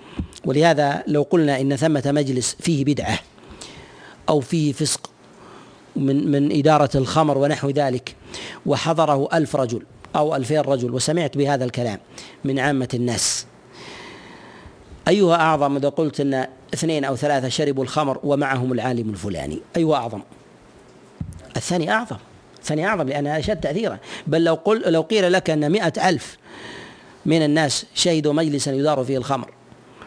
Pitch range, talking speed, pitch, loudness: 130-155 Hz, 135 wpm, 145 Hz, -20 LUFS